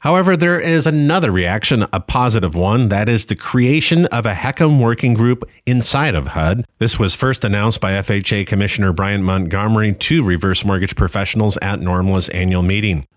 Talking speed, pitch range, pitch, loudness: 170 wpm, 95-125 Hz, 105 Hz, -15 LUFS